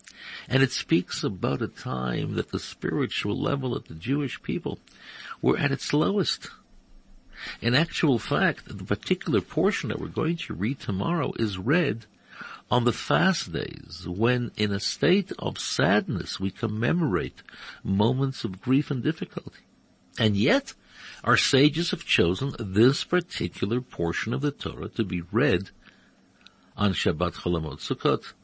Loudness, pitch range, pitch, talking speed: -26 LUFS, 95-140 Hz, 120 Hz, 140 wpm